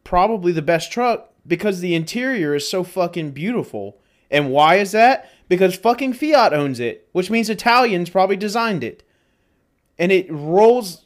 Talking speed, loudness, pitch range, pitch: 155 wpm, -18 LUFS, 160-230 Hz, 185 Hz